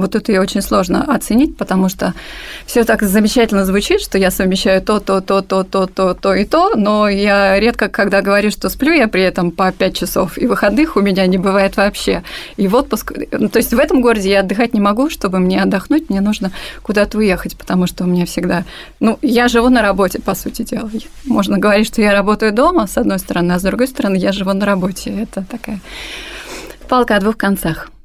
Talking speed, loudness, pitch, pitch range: 210 wpm, -14 LUFS, 205 Hz, 190-230 Hz